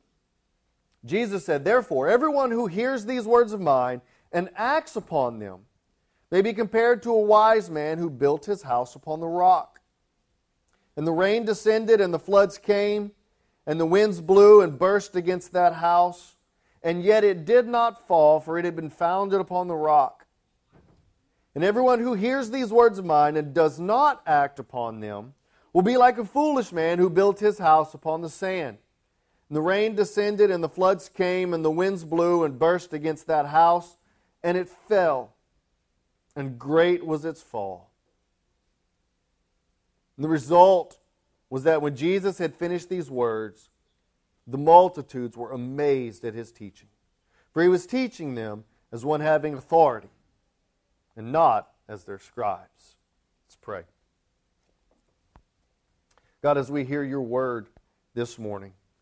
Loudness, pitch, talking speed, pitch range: -23 LUFS, 165 Hz, 155 wpm, 120-195 Hz